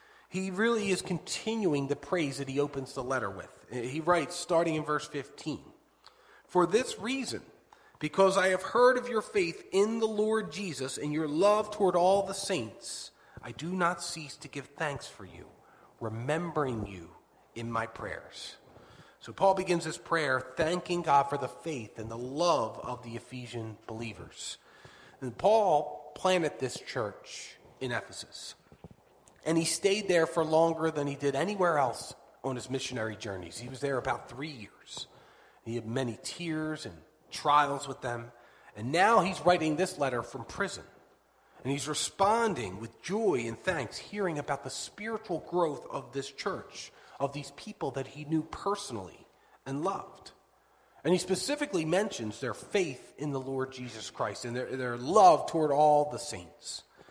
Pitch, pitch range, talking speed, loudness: 150 Hz, 130-180 Hz, 165 wpm, -31 LUFS